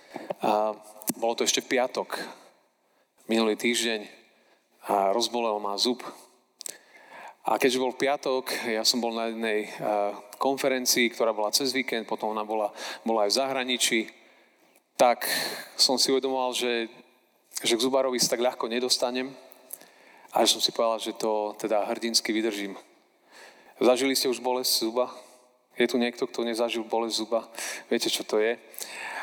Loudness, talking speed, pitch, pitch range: -26 LUFS, 145 wpm, 120 Hz, 110-125 Hz